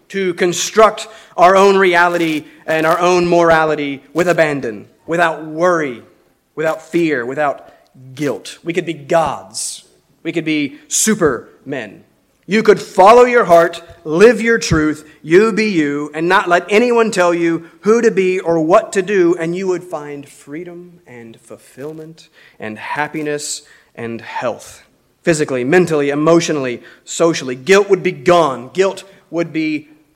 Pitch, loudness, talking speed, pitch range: 170 Hz, -14 LUFS, 140 wpm, 150-190 Hz